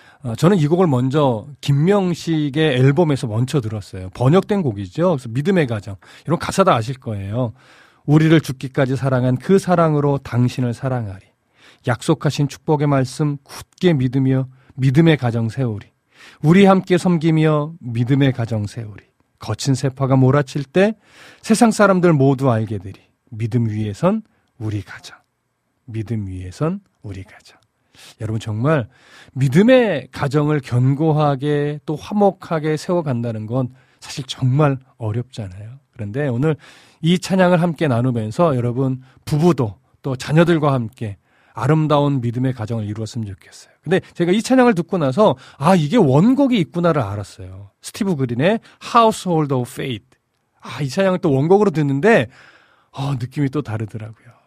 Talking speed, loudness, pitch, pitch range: 325 characters per minute, -18 LUFS, 135 Hz, 120-165 Hz